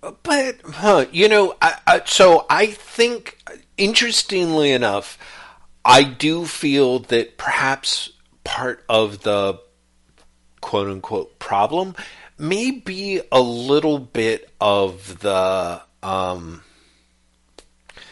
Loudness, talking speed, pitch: -18 LUFS, 100 wpm, 130 Hz